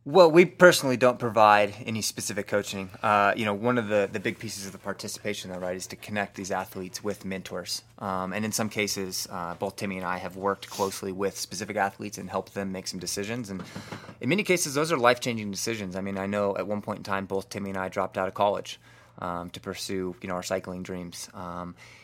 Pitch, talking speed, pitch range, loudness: 100 Hz, 235 wpm, 95-110 Hz, -27 LUFS